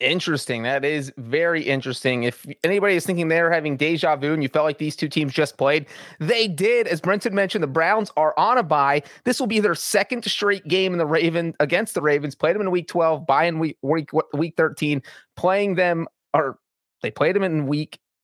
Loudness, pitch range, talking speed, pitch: -21 LUFS, 150-185 Hz, 215 wpm, 160 Hz